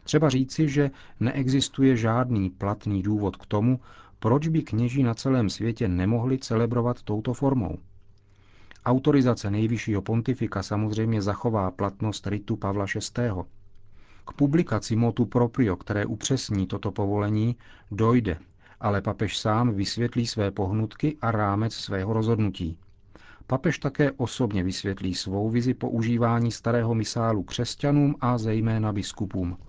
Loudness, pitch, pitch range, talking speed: -26 LUFS, 110 Hz, 100-120 Hz, 120 wpm